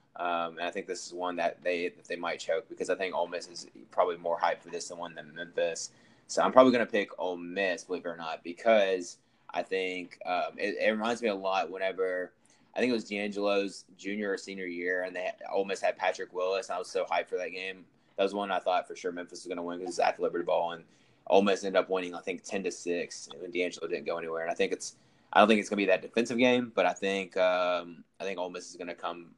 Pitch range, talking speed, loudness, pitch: 90-115 Hz, 275 wpm, -31 LUFS, 95 Hz